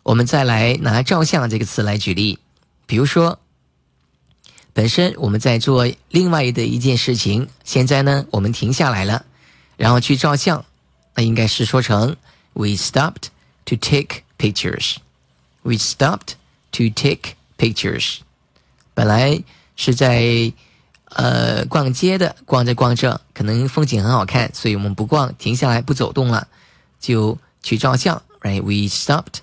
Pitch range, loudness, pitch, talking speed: 105-135 Hz, -17 LUFS, 120 Hz, 295 characters per minute